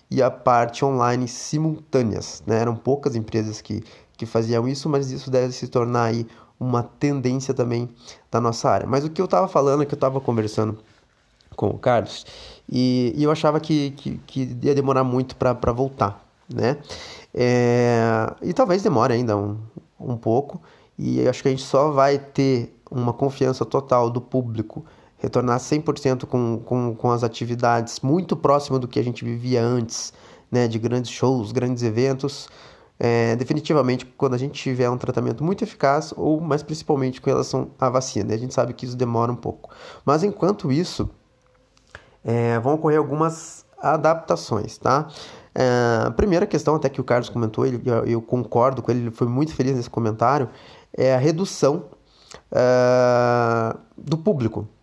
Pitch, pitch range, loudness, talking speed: 125 Hz, 120-140 Hz, -22 LUFS, 170 wpm